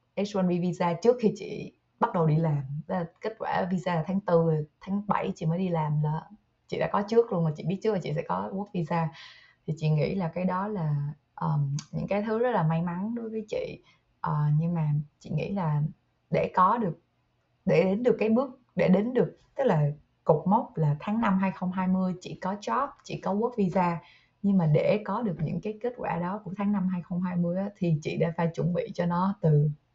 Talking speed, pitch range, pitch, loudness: 225 wpm, 160-200 Hz, 180 Hz, -28 LUFS